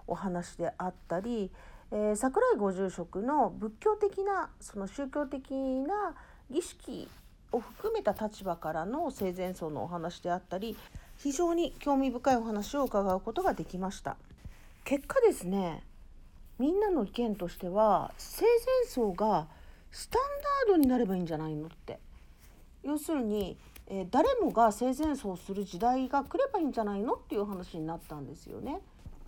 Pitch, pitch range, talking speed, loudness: 225 Hz, 185-285 Hz, 295 characters per minute, -32 LUFS